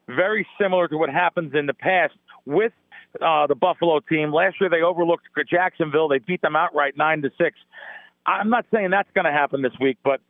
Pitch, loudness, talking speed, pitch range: 170 Hz, -21 LUFS, 205 wpm, 150-185 Hz